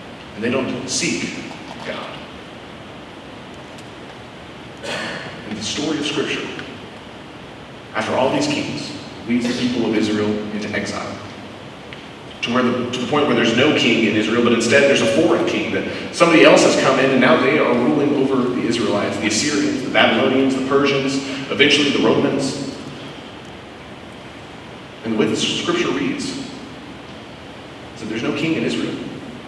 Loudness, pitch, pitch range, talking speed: -18 LUFS, 125 Hz, 115-140 Hz, 155 wpm